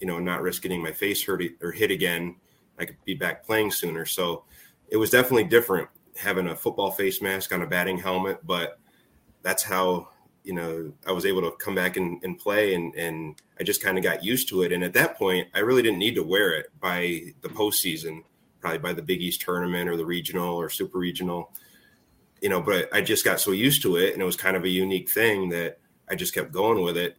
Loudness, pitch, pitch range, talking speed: -25 LUFS, 90 Hz, 85-95 Hz, 235 wpm